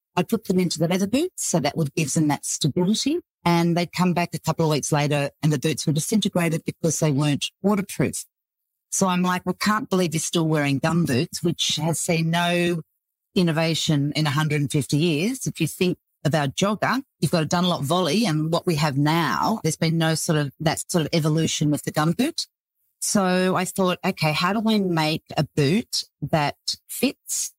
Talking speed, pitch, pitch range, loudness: 200 wpm, 170 Hz, 155-185 Hz, -23 LUFS